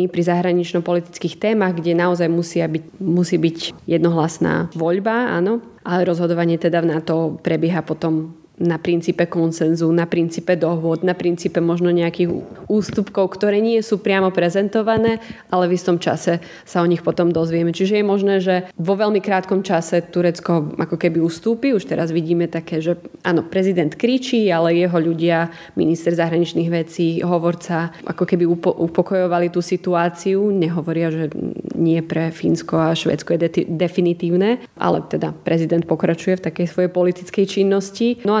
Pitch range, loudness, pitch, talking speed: 165-185 Hz, -19 LUFS, 175 Hz, 150 wpm